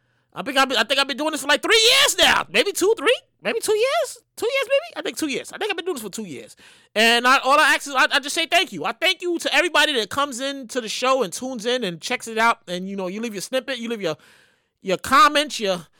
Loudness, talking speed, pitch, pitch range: -20 LUFS, 295 wpm, 275 Hz, 230-325 Hz